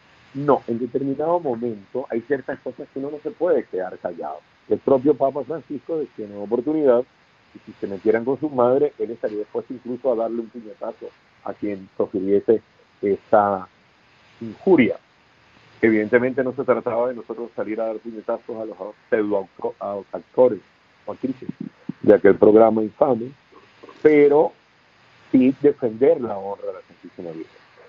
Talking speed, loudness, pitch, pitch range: 155 wpm, -21 LUFS, 125 Hz, 110-145 Hz